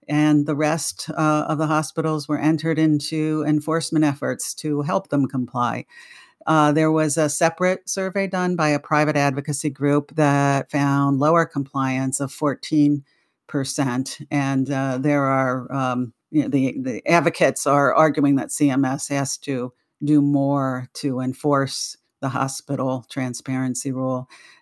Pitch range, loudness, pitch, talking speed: 135-155 Hz, -21 LUFS, 145 Hz, 135 wpm